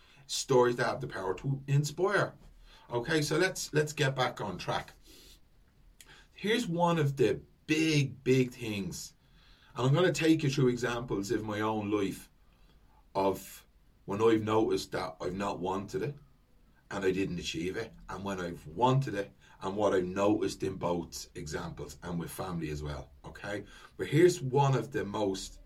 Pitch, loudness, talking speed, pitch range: 120 Hz, -31 LUFS, 170 wpm, 95-140 Hz